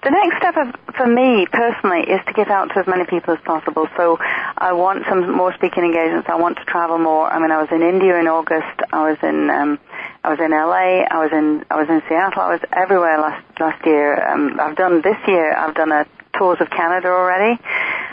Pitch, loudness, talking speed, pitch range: 170 Hz, -16 LUFS, 230 wpm, 160-190 Hz